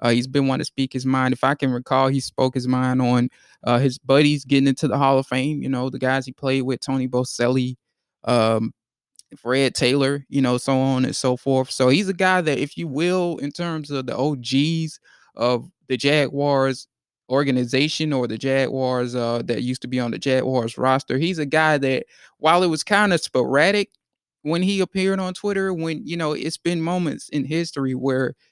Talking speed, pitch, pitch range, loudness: 205 wpm, 135 Hz, 130-155 Hz, -21 LUFS